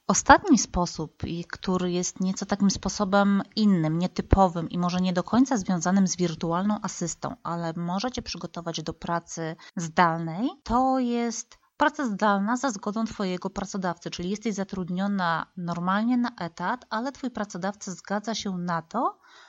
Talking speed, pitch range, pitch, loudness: 140 wpm, 175-225 Hz, 195 Hz, -26 LUFS